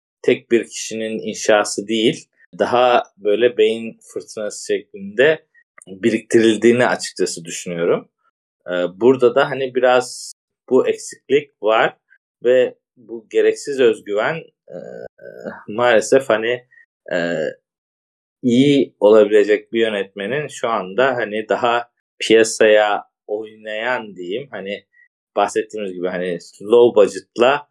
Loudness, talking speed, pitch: -18 LUFS, 100 wpm, 125 Hz